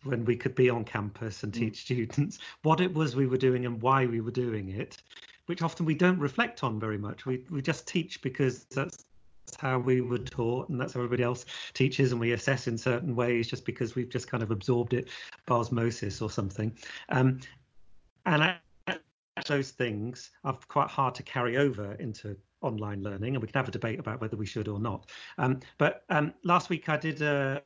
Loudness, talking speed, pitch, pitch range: -30 LUFS, 210 wpm, 125 Hz, 115-135 Hz